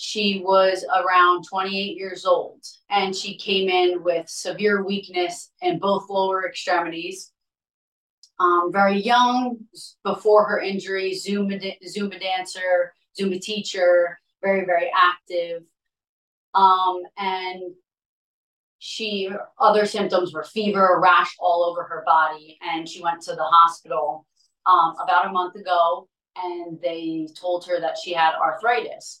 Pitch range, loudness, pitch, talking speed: 175-195 Hz, -21 LUFS, 185 Hz, 125 wpm